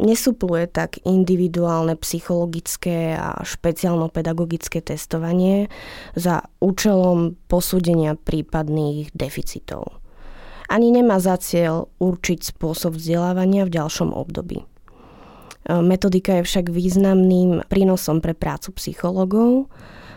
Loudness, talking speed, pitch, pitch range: -20 LUFS, 90 wpm, 175 Hz, 165-185 Hz